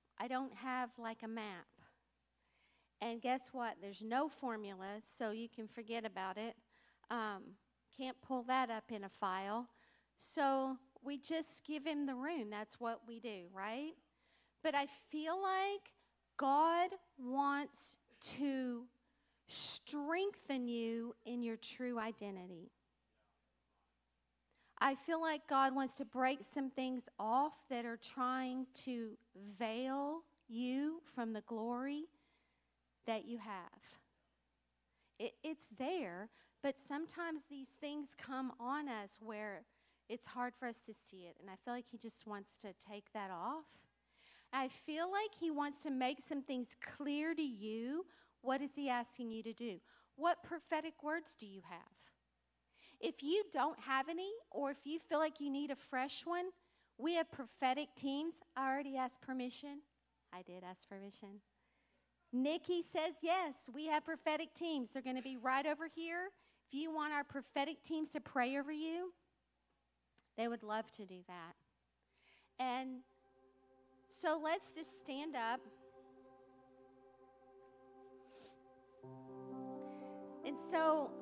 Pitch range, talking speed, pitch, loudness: 210-295 Hz, 140 wpm, 255 Hz, -42 LUFS